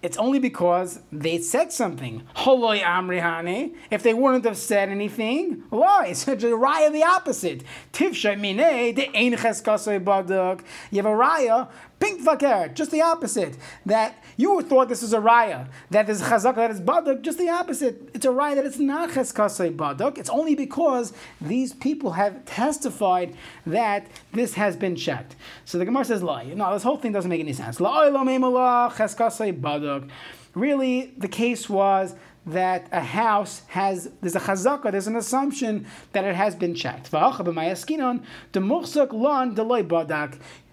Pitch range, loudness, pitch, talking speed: 190-265 Hz, -23 LUFS, 225 Hz, 155 wpm